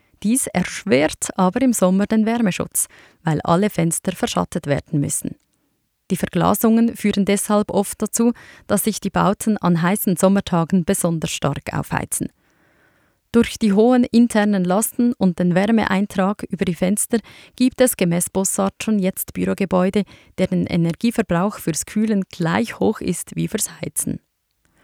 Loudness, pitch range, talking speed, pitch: -19 LUFS, 180-220 Hz, 140 wpm, 195 Hz